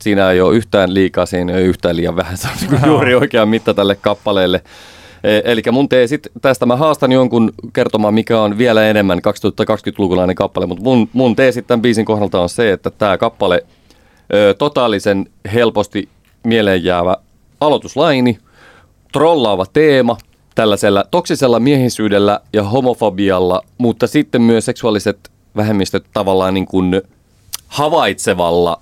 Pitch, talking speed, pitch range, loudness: 105 Hz, 135 wpm, 95-120 Hz, -14 LUFS